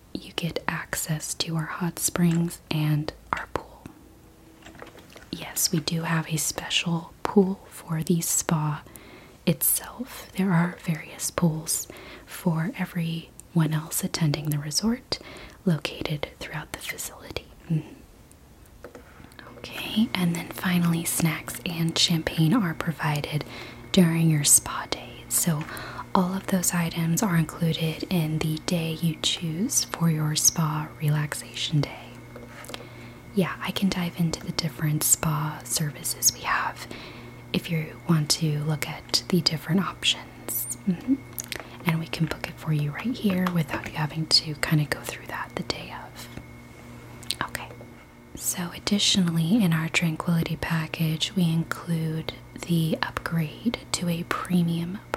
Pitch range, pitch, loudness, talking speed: 155-175 Hz, 165 Hz, -26 LUFS, 135 wpm